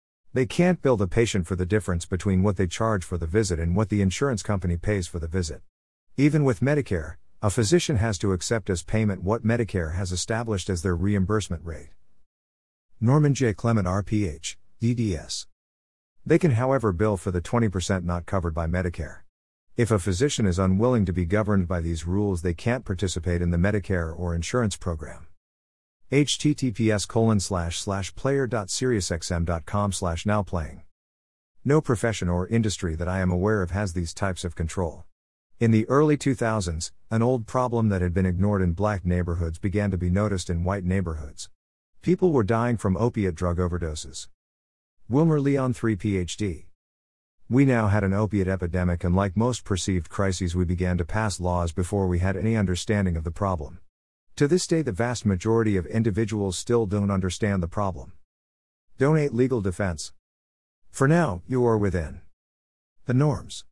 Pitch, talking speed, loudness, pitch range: 95 Hz, 160 wpm, -25 LUFS, 85-110 Hz